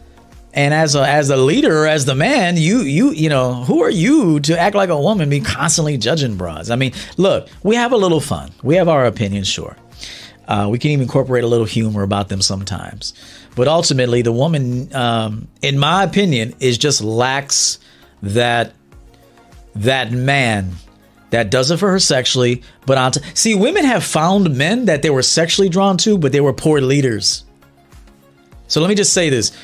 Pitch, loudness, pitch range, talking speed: 130 Hz, -15 LUFS, 110-160 Hz, 190 wpm